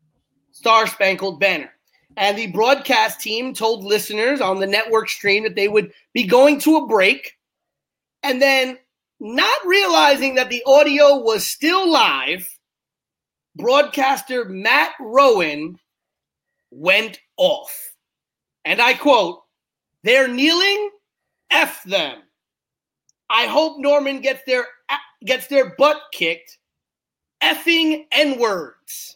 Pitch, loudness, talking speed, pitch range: 255 Hz, -17 LUFS, 115 wpm, 215-290 Hz